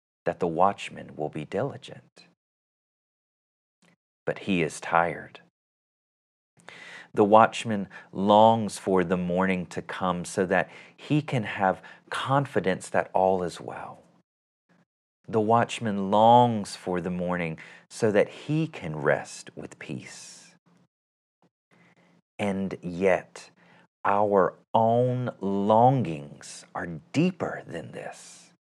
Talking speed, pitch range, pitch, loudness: 105 wpm, 85-115 Hz, 95 Hz, -25 LUFS